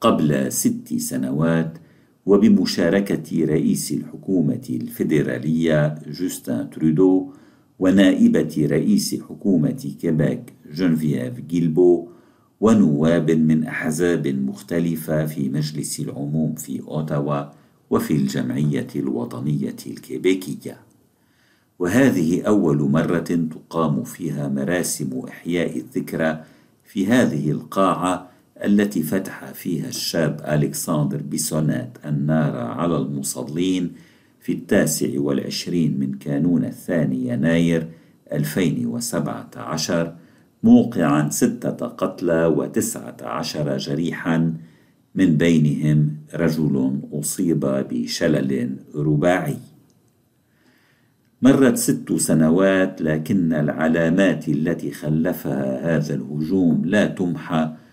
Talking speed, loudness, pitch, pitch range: 85 wpm, -21 LUFS, 80 Hz, 75-85 Hz